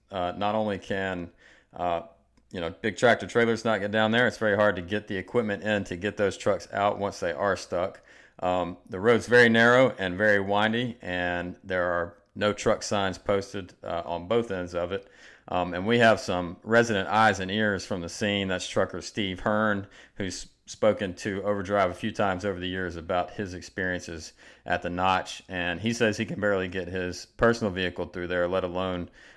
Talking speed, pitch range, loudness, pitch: 200 wpm, 90-105 Hz, -27 LUFS, 95 Hz